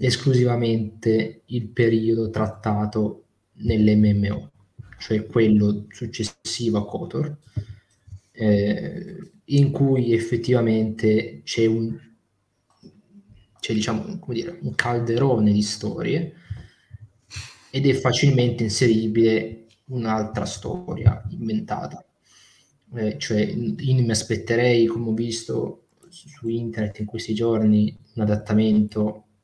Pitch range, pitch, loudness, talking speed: 105-120 Hz, 110 Hz, -22 LUFS, 100 wpm